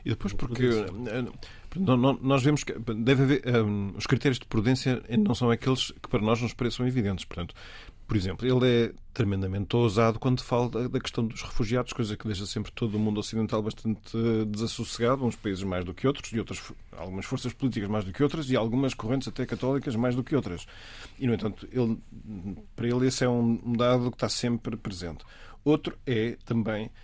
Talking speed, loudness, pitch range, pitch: 190 wpm, -28 LUFS, 110-125 Hz, 115 Hz